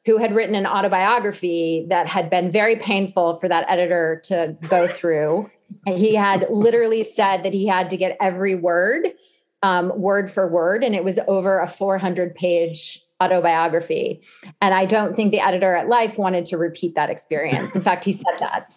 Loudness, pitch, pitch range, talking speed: -20 LUFS, 190 Hz, 175-200 Hz, 185 wpm